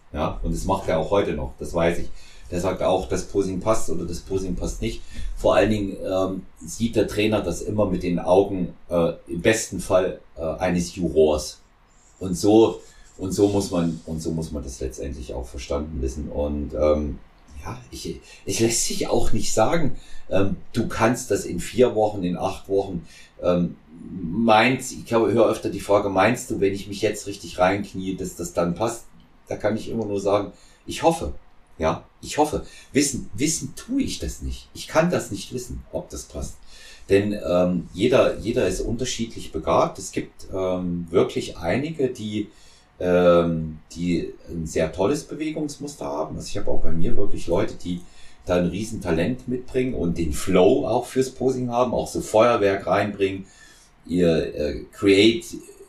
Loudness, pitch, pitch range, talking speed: -23 LUFS, 95 Hz, 85-110 Hz, 185 wpm